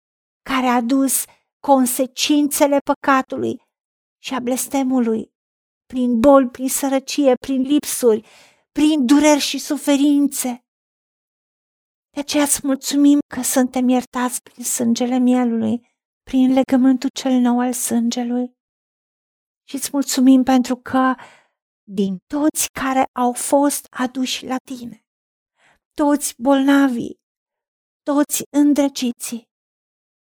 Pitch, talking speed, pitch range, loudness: 260 Hz, 100 wpm, 250-280 Hz, -18 LUFS